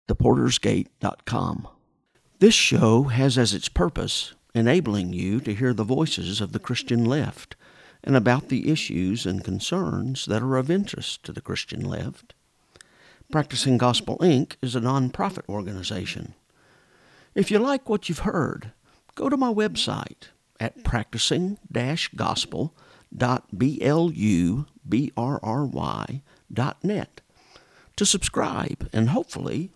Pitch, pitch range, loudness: 125 Hz, 110-155 Hz, -24 LUFS